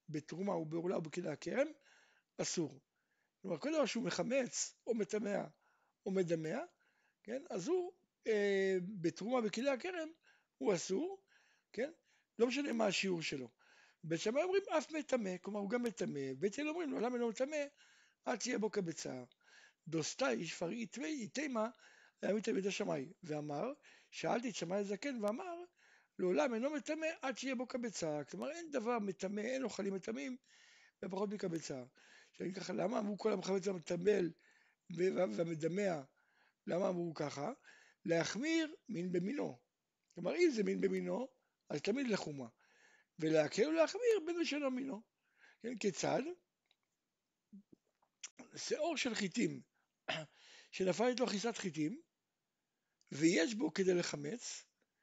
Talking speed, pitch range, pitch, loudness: 130 wpm, 180-275 Hz, 215 Hz, -39 LUFS